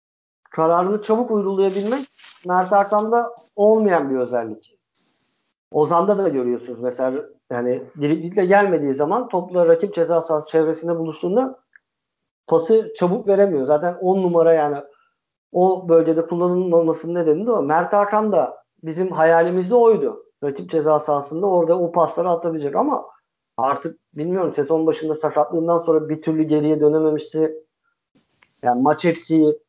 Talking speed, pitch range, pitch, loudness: 125 wpm, 155-200 Hz, 165 Hz, -19 LUFS